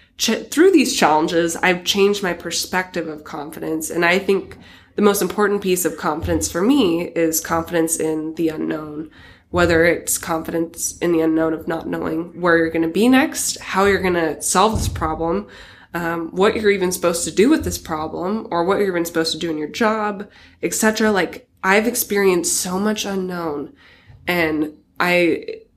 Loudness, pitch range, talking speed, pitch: -19 LUFS, 165-200 Hz, 175 wpm, 175 Hz